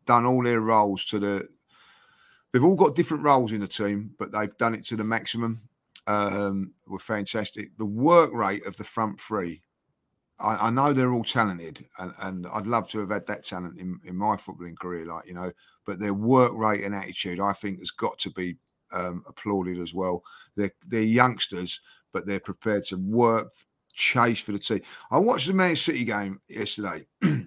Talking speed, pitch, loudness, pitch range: 195 wpm, 105 Hz, -26 LUFS, 95-115 Hz